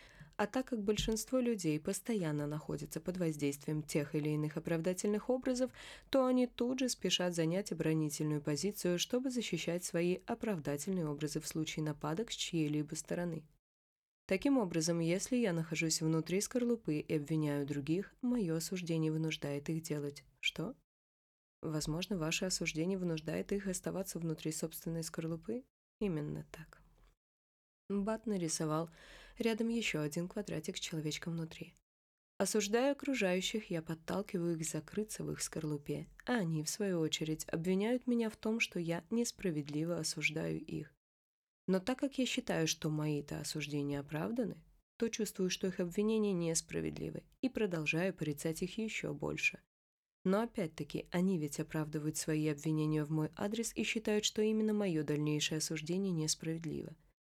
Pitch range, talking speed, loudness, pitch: 155-210 Hz, 135 wpm, -37 LUFS, 170 Hz